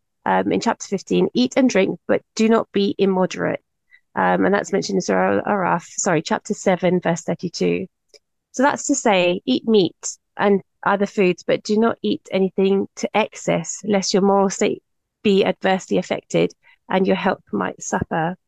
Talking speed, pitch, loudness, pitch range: 170 wpm, 195 Hz, -20 LUFS, 185-220 Hz